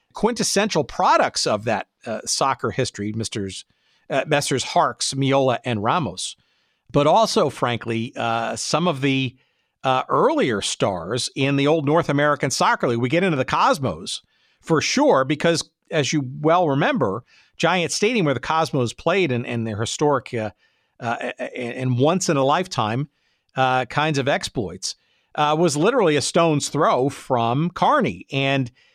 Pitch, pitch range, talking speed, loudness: 140 Hz, 125-160 Hz, 150 wpm, -21 LUFS